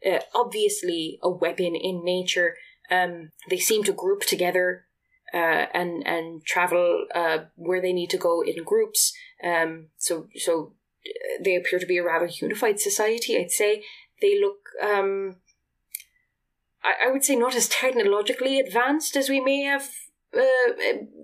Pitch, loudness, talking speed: 250 Hz, -24 LUFS, 150 wpm